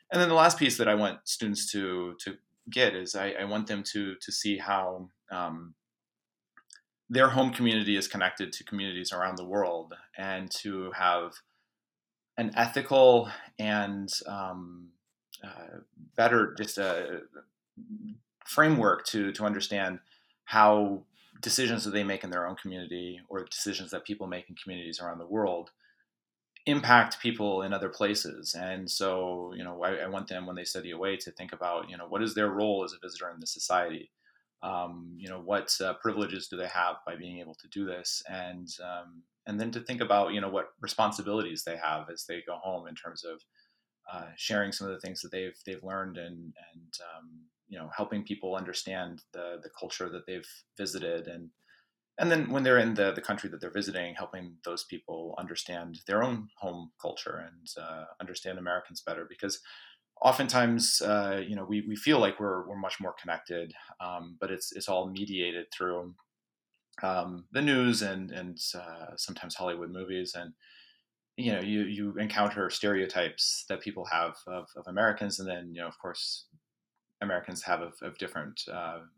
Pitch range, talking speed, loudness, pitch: 90-105 Hz, 180 wpm, -30 LUFS, 95 Hz